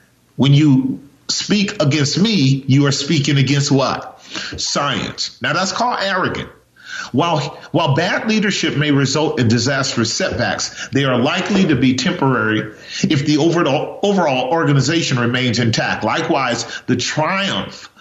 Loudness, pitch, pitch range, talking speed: -16 LUFS, 145 Hz, 130-170 Hz, 135 wpm